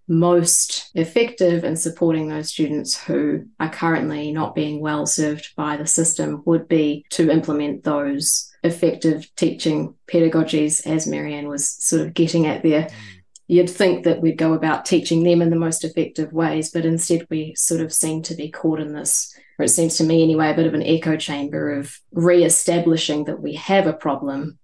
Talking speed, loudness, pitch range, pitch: 185 wpm, -19 LUFS, 150-165 Hz, 160 Hz